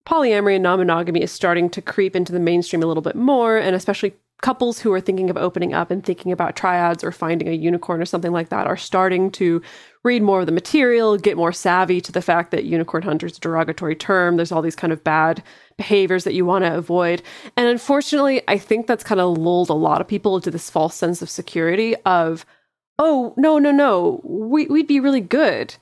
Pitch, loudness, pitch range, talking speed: 185 Hz, -19 LUFS, 170-220 Hz, 220 wpm